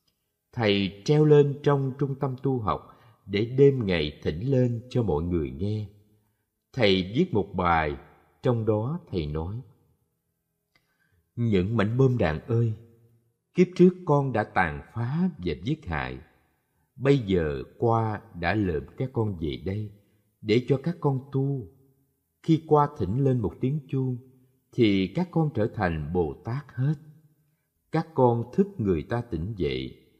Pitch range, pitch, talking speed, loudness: 95-140 Hz, 115 Hz, 145 wpm, -26 LUFS